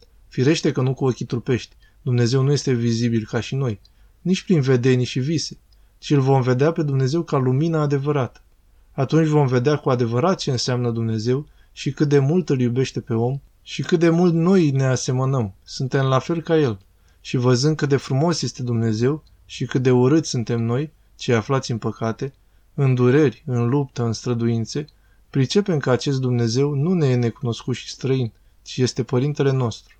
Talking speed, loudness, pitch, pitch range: 185 wpm, -21 LUFS, 130 Hz, 120-145 Hz